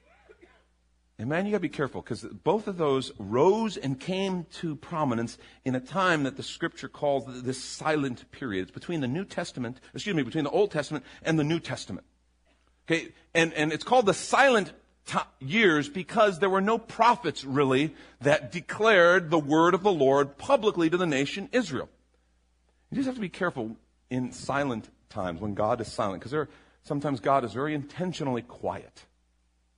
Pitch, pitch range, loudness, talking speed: 145 Hz, 125-175 Hz, -27 LUFS, 175 wpm